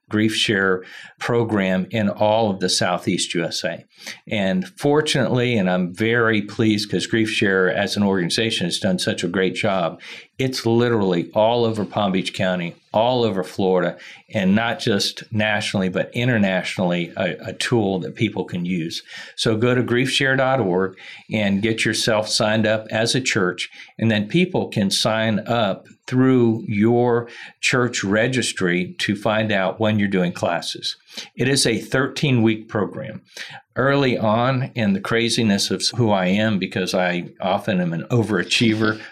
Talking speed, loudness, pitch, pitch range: 155 wpm, -20 LUFS, 110 Hz, 95-120 Hz